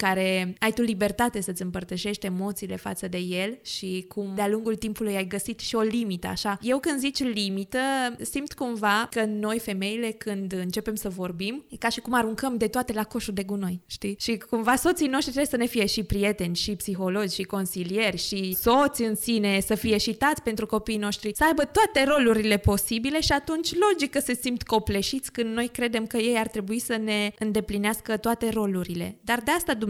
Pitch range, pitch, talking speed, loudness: 200-240 Hz, 220 Hz, 195 wpm, -26 LUFS